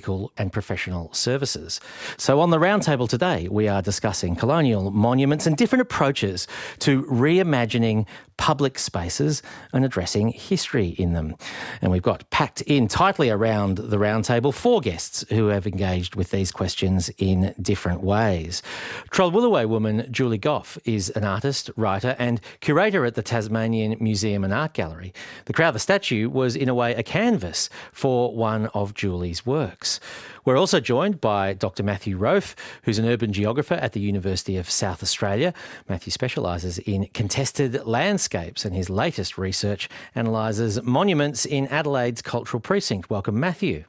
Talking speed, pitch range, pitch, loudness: 150 wpm, 100-135 Hz, 110 Hz, -23 LUFS